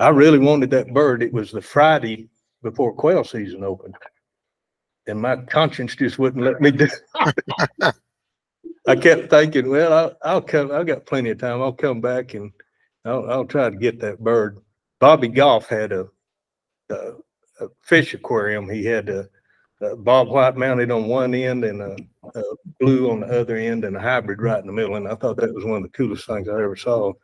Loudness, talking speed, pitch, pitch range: -19 LUFS, 200 wpm, 125 Hz, 110-140 Hz